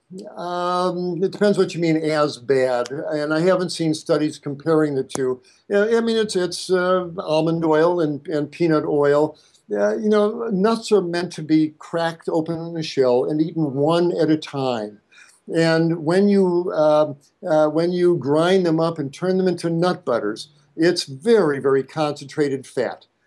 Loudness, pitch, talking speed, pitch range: -20 LUFS, 165 Hz, 175 wpm, 150-180 Hz